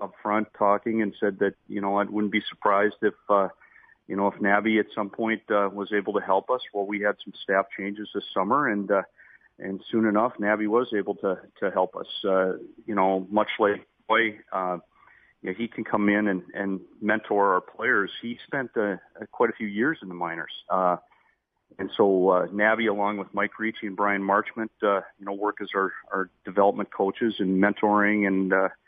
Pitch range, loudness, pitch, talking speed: 100-105 Hz, -26 LUFS, 100 Hz, 205 wpm